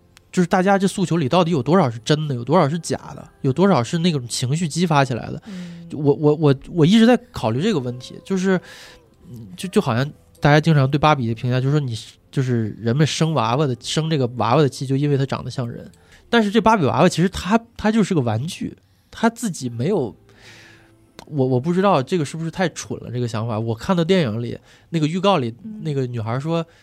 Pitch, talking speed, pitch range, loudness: 150 Hz, 325 characters per minute, 125-180 Hz, -20 LUFS